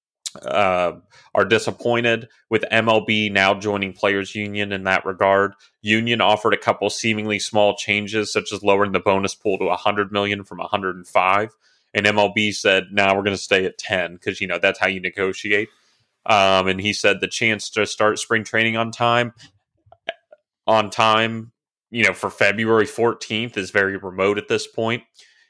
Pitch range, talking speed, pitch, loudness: 100-110 Hz, 170 wpm, 105 Hz, -19 LUFS